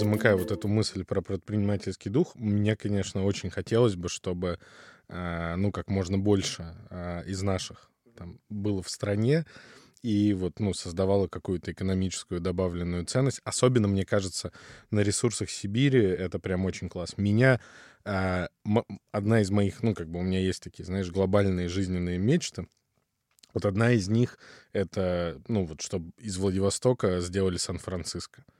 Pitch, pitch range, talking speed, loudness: 100 Hz, 90-105 Hz, 145 wpm, -28 LUFS